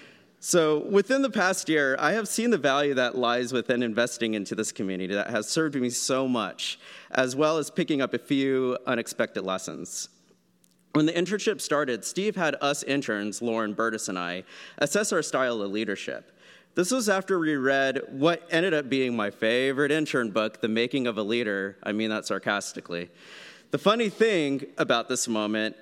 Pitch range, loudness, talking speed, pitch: 110-155 Hz, -26 LUFS, 180 wpm, 130 Hz